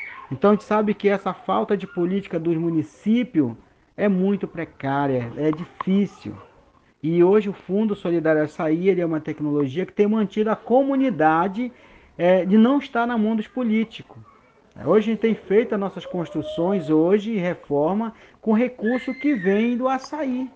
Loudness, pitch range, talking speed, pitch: -22 LUFS, 170-220 Hz, 160 wpm, 200 Hz